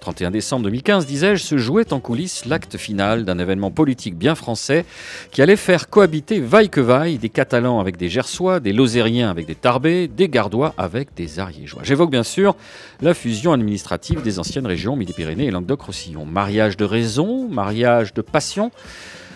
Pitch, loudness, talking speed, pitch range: 125 Hz, -18 LUFS, 170 wpm, 105-165 Hz